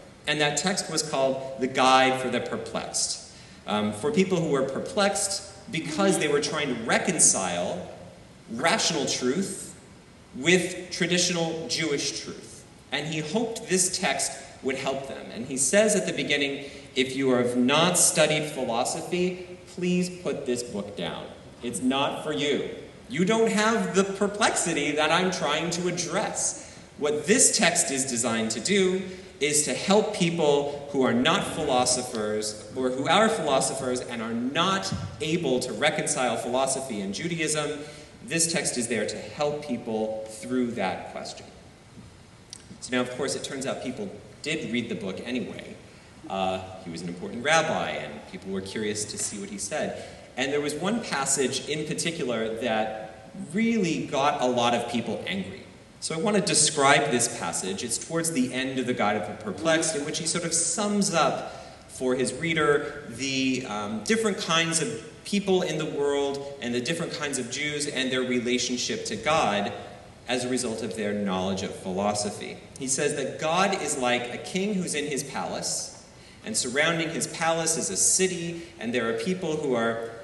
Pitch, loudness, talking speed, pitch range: 145 Hz, -26 LUFS, 170 wpm, 125-175 Hz